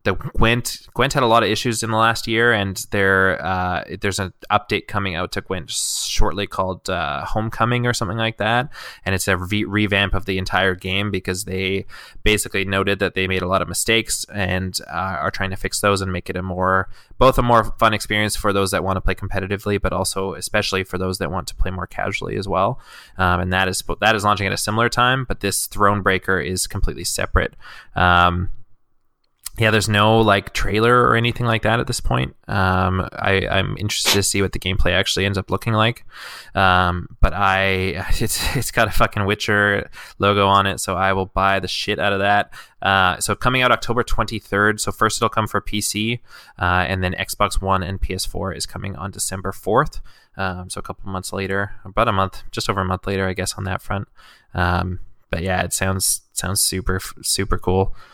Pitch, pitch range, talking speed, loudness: 100 Hz, 95-105 Hz, 210 wpm, -20 LUFS